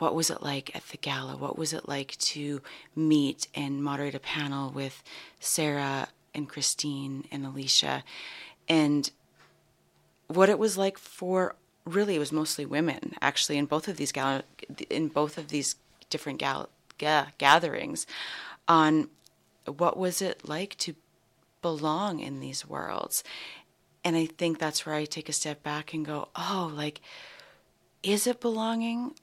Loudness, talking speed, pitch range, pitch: -29 LUFS, 150 wpm, 145-170 Hz, 155 Hz